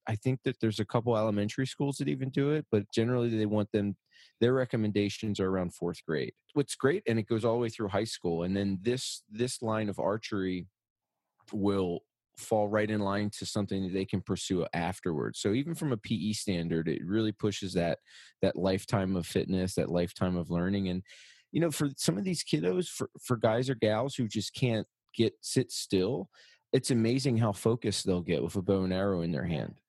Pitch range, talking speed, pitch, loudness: 95-120 Hz, 210 wpm, 105 Hz, -31 LUFS